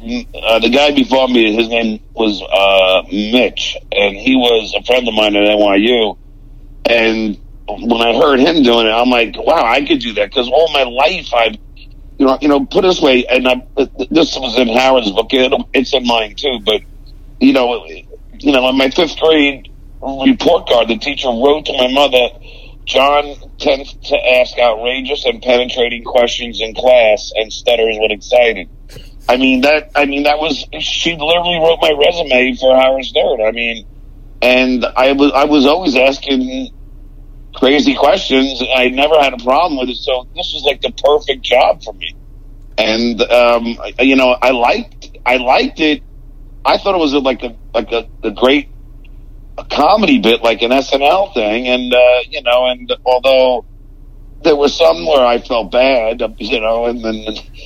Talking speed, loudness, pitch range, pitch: 180 wpm, -12 LUFS, 115-140 Hz, 125 Hz